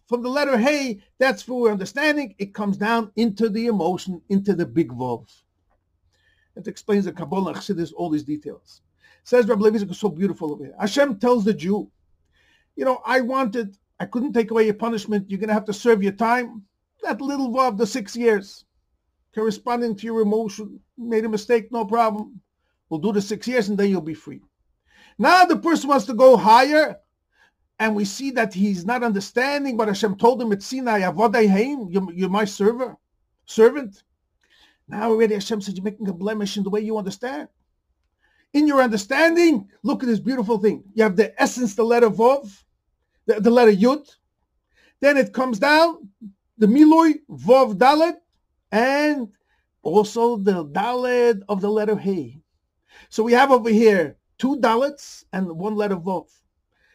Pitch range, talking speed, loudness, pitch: 200-250 Hz, 170 wpm, -20 LUFS, 225 Hz